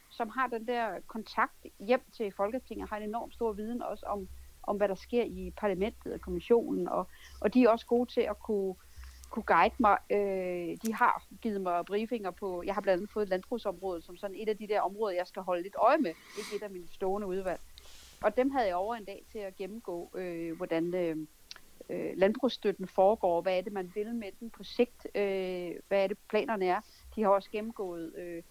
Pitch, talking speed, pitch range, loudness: 200 Hz, 215 wpm, 180-225 Hz, -32 LUFS